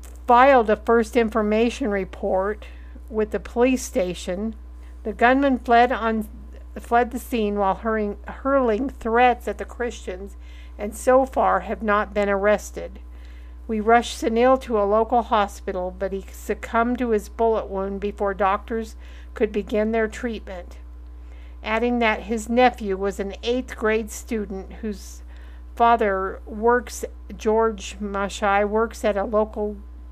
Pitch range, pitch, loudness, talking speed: 190-235 Hz, 210 Hz, -22 LUFS, 130 wpm